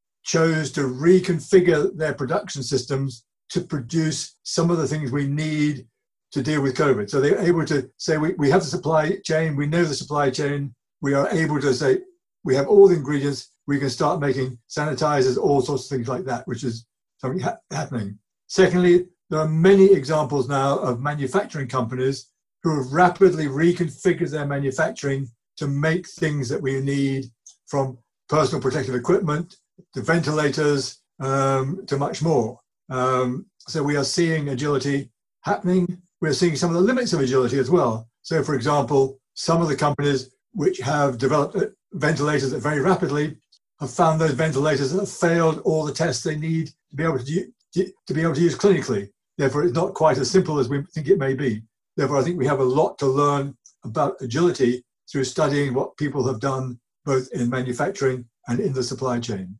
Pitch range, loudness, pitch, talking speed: 135-170 Hz, -22 LUFS, 145 Hz, 180 wpm